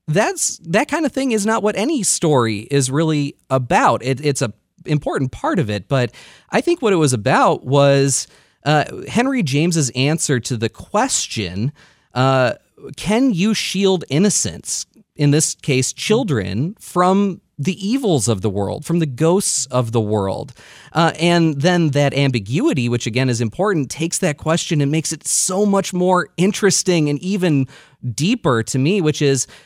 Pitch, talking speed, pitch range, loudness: 150 Hz, 165 wpm, 130-180 Hz, -18 LUFS